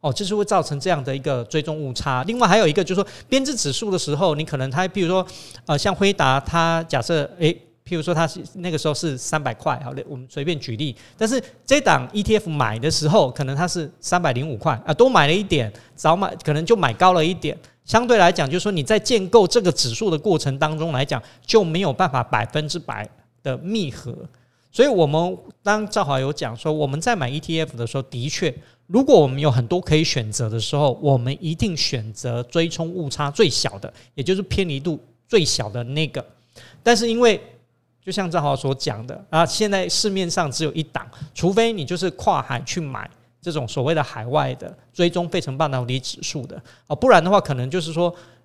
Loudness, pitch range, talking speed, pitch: -20 LUFS, 135-180 Hz, 315 characters per minute, 155 Hz